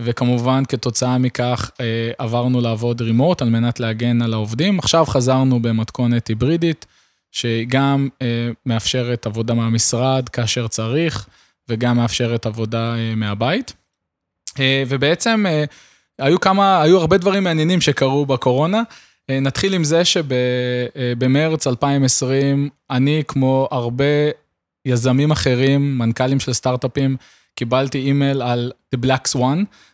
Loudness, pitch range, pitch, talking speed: -18 LUFS, 120-140 Hz, 130 Hz, 110 wpm